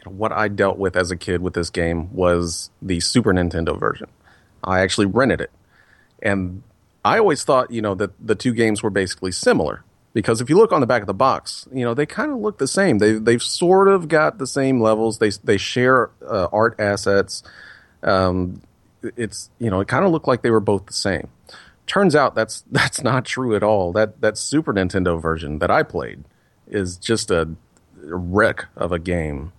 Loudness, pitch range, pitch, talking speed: -19 LUFS, 90-120 Hz, 105 Hz, 205 wpm